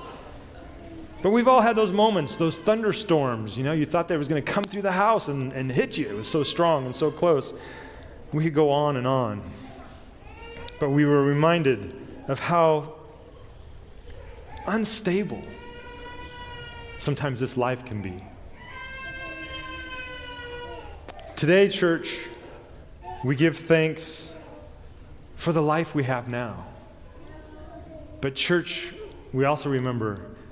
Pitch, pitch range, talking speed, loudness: 150 Hz, 120-170 Hz, 130 wpm, -24 LUFS